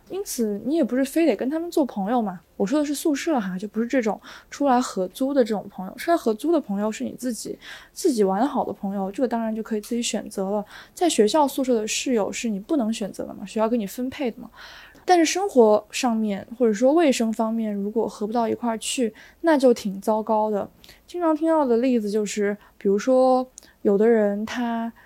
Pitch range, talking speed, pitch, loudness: 210-265 Hz, 320 characters per minute, 230 Hz, -23 LUFS